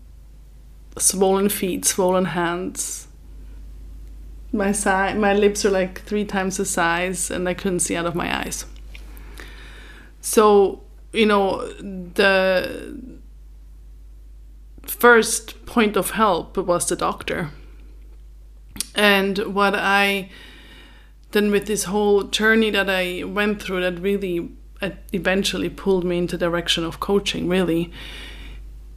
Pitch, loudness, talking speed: 185 Hz, -20 LUFS, 115 wpm